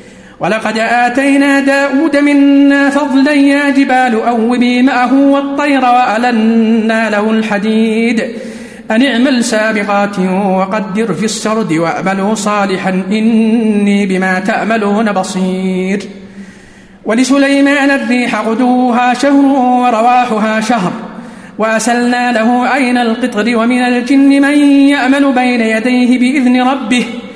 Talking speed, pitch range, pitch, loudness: 95 wpm, 215-255 Hz, 235 Hz, -10 LUFS